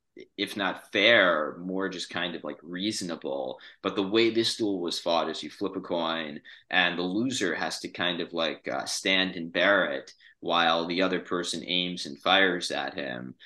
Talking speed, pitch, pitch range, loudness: 190 wpm, 90 Hz, 85-95 Hz, -27 LUFS